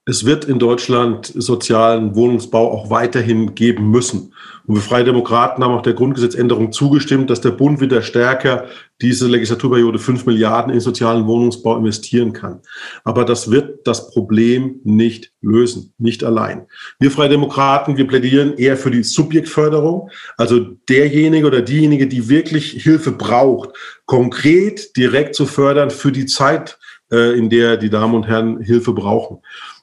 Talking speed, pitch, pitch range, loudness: 150 wpm, 120 Hz, 115-135 Hz, -14 LUFS